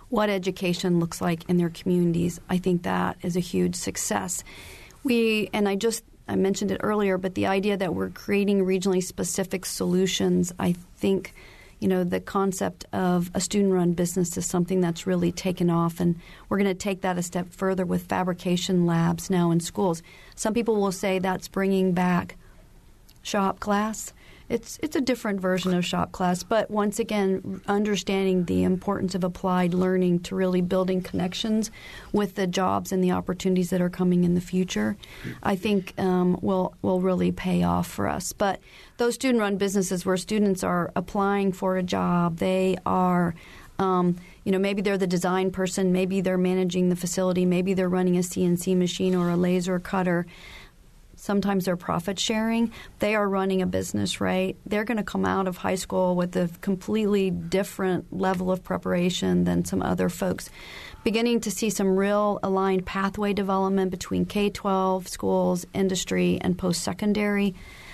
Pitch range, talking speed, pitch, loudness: 180-195 Hz, 175 wpm, 185 Hz, -25 LUFS